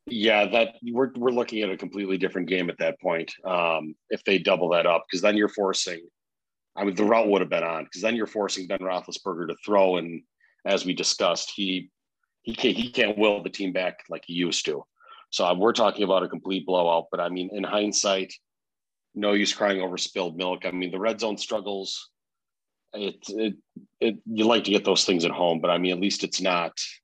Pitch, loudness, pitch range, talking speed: 100 Hz, -25 LUFS, 90-105 Hz, 220 wpm